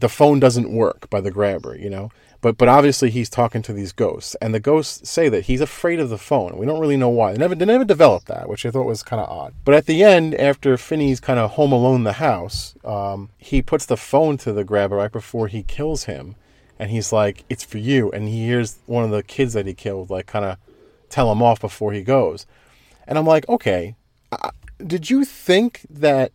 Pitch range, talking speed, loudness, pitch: 105-145 Hz, 245 wpm, -19 LUFS, 120 Hz